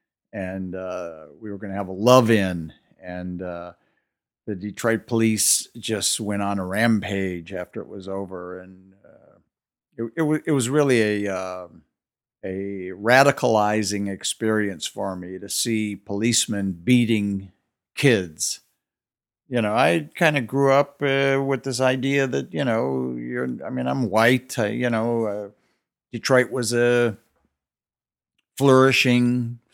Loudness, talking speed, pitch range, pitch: -22 LUFS, 145 wpm, 95-125 Hz, 105 Hz